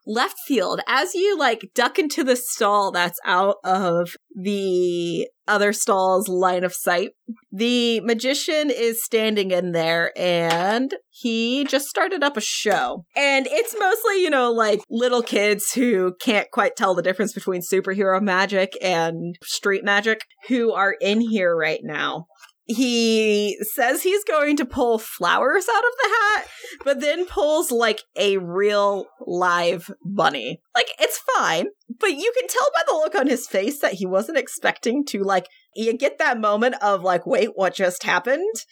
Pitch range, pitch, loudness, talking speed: 190-265 Hz, 215 Hz, -21 LUFS, 165 wpm